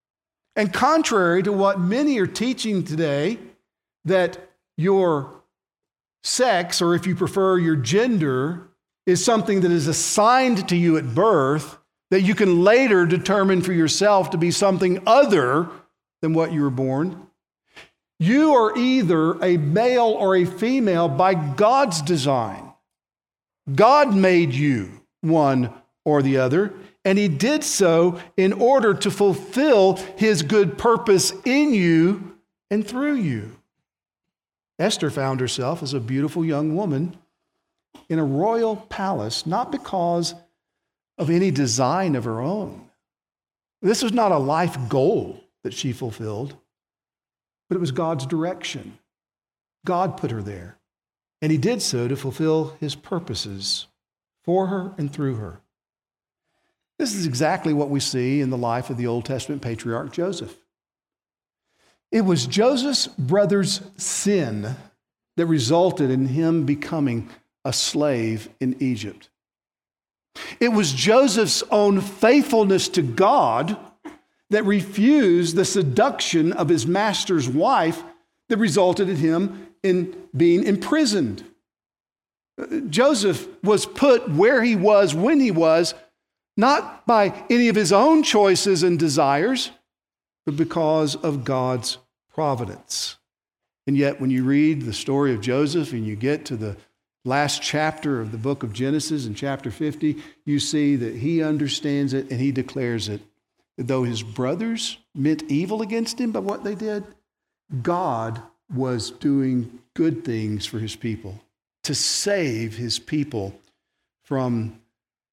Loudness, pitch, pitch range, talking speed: -21 LUFS, 170 Hz, 140-200 Hz, 135 wpm